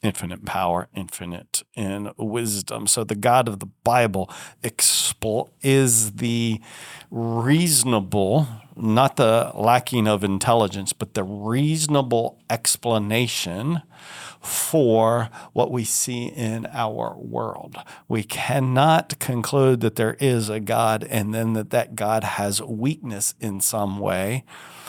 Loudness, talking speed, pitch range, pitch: -22 LUFS, 115 wpm, 105-125 Hz, 115 Hz